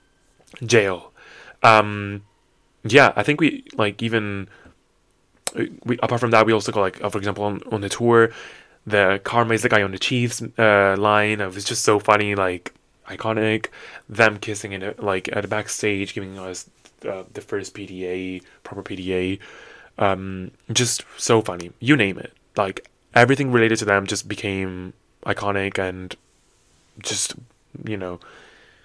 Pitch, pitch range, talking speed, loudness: 105 Hz, 95-115 Hz, 155 wpm, -20 LUFS